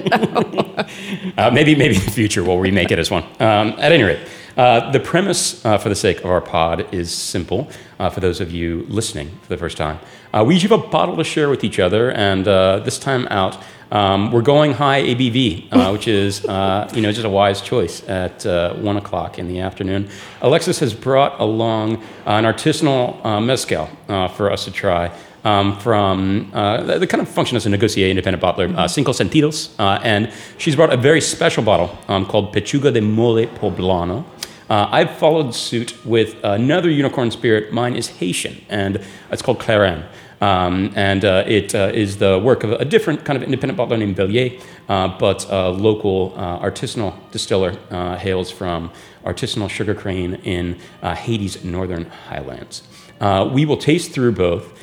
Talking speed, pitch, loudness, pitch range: 190 wpm, 105 Hz, -17 LUFS, 95-125 Hz